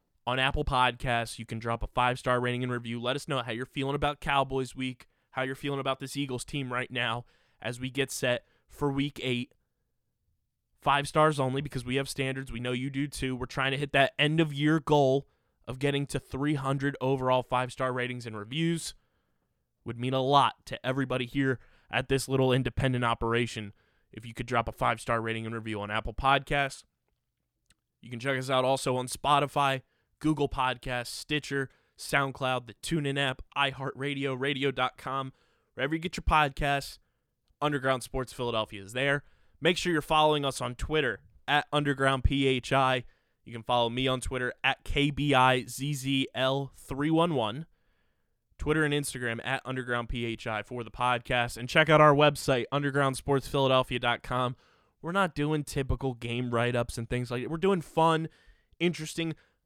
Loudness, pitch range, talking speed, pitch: -29 LUFS, 125-140 Hz, 170 wpm, 130 Hz